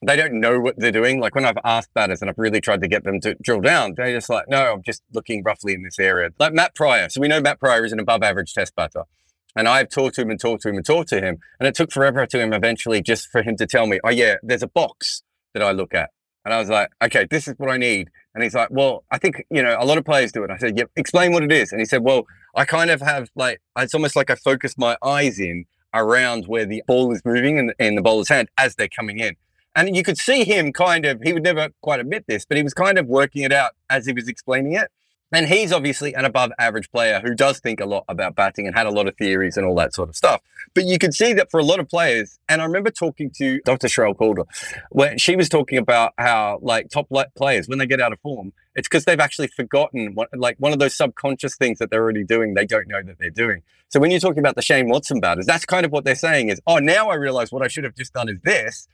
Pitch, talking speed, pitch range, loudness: 130 Hz, 285 wpm, 115-150 Hz, -19 LUFS